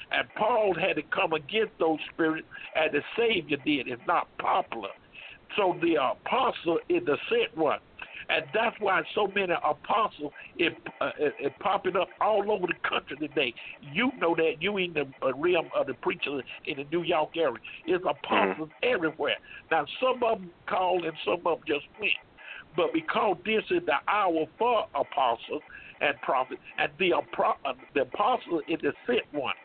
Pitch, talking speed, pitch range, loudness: 195 Hz, 180 wpm, 165-260 Hz, -28 LUFS